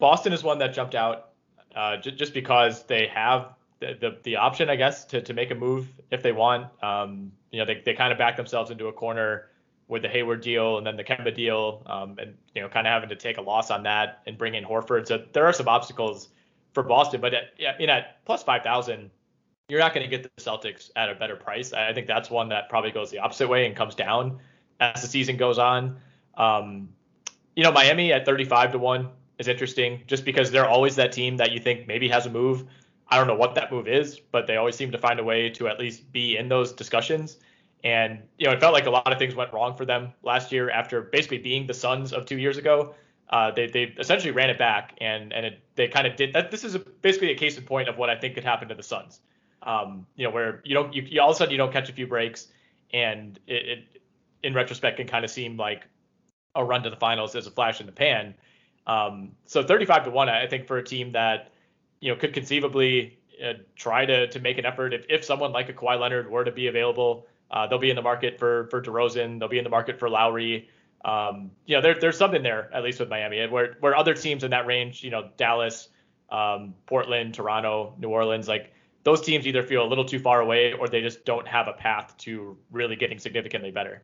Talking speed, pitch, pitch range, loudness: 250 wpm, 120 Hz, 115-130 Hz, -24 LUFS